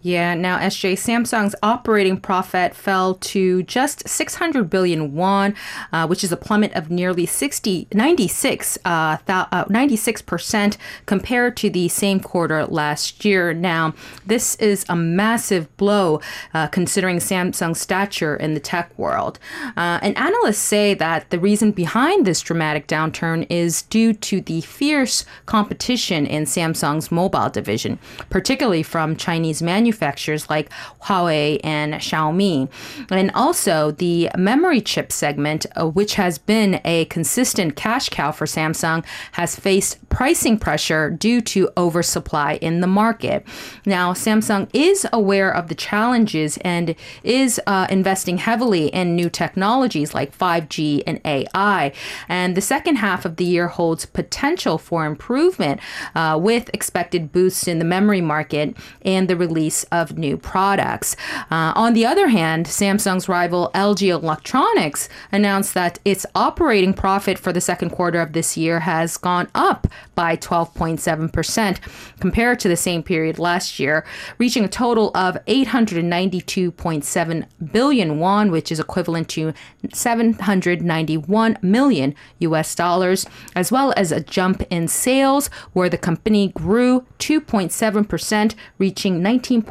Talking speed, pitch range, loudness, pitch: 140 wpm, 165-210 Hz, -19 LUFS, 180 Hz